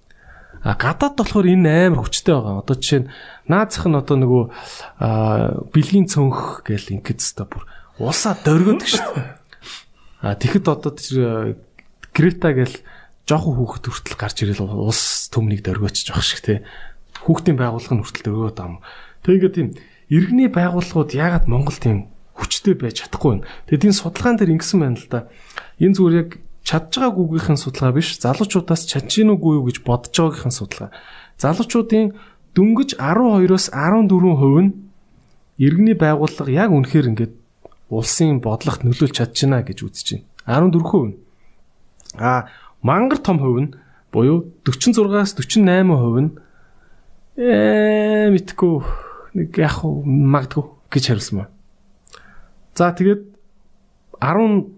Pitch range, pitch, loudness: 120-185 Hz, 150 Hz, -17 LUFS